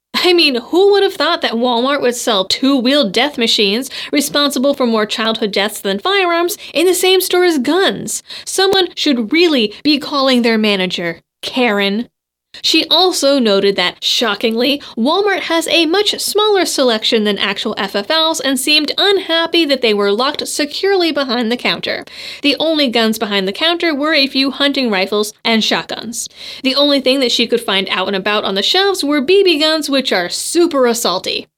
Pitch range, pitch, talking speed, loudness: 220-320 Hz, 270 Hz, 175 wpm, -13 LUFS